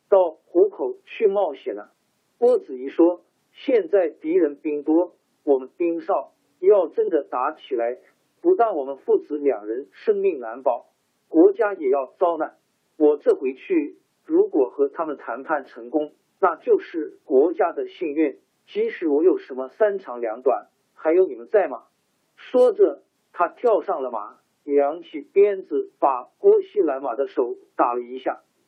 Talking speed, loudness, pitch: 220 characters per minute, -22 LUFS, 375 Hz